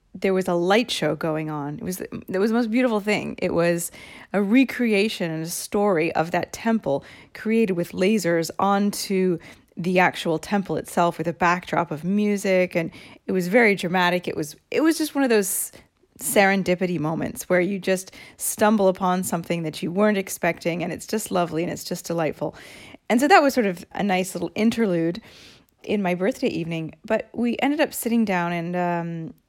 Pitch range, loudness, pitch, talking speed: 170-210 Hz, -23 LUFS, 185 Hz, 190 wpm